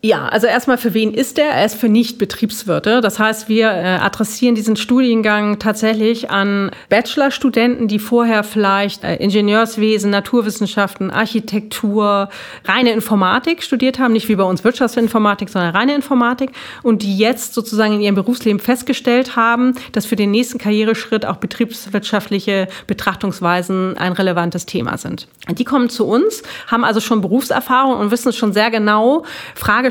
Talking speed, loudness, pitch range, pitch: 155 wpm, -15 LUFS, 205-240 Hz, 220 Hz